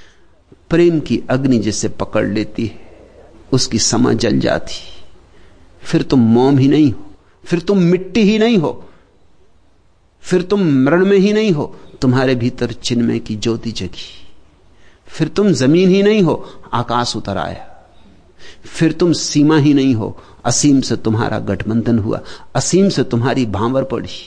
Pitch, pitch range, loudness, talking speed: 125 Hz, 110-160 Hz, -15 LUFS, 150 wpm